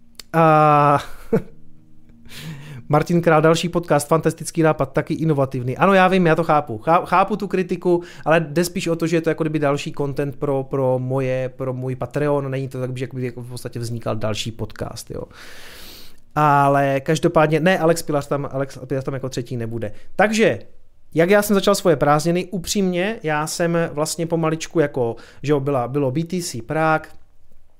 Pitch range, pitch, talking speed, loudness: 130-165 Hz, 150 Hz, 170 wpm, -20 LUFS